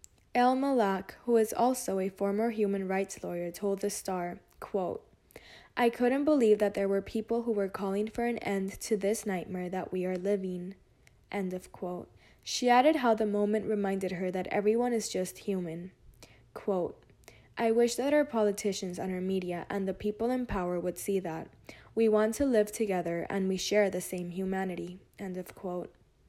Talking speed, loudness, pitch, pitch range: 185 wpm, -31 LUFS, 200 Hz, 185-225 Hz